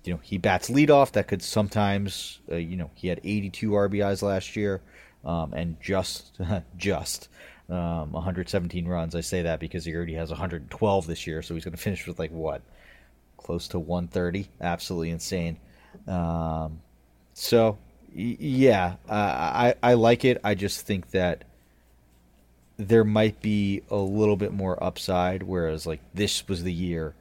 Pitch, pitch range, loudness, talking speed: 90 Hz, 80-100 Hz, -26 LUFS, 165 wpm